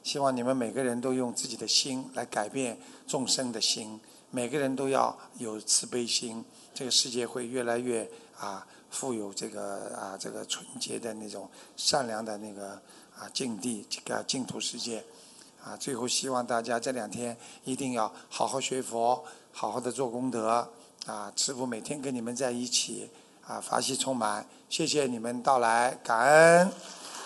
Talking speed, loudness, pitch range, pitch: 245 characters per minute, -30 LUFS, 115-130 Hz, 125 Hz